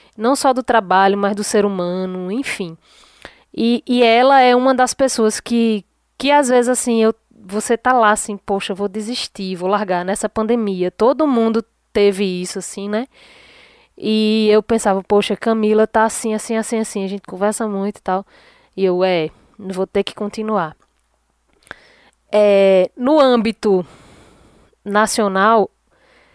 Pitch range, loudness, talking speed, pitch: 195-230 Hz, -17 LUFS, 150 wpm, 215 Hz